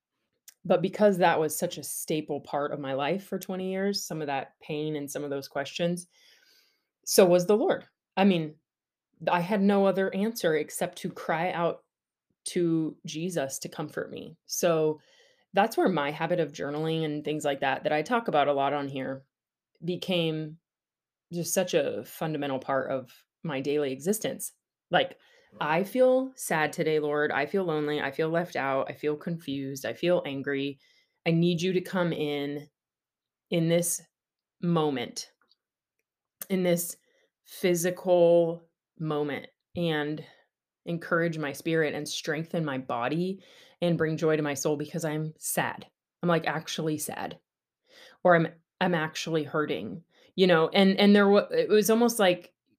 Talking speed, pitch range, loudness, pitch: 160 wpm, 150-185 Hz, -28 LUFS, 165 Hz